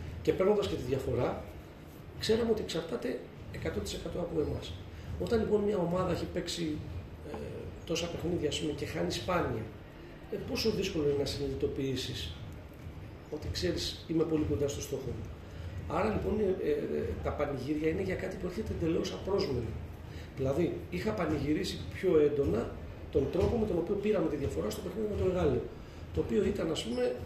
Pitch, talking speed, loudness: 155 Hz, 165 wpm, -33 LUFS